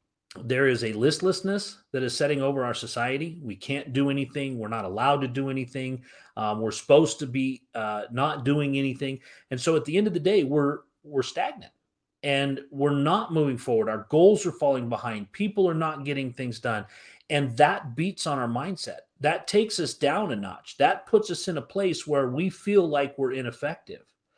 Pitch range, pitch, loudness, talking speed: 130-160 Hz, 140 Hz, -26 LUFS, 195 wpm